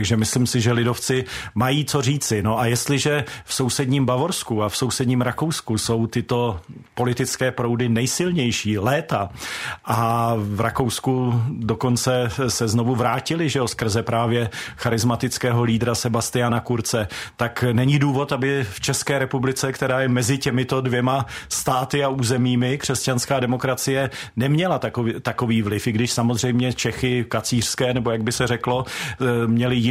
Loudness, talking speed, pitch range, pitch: -21 LUFS, 140 wpm, 115-130 Hz, 125 Hz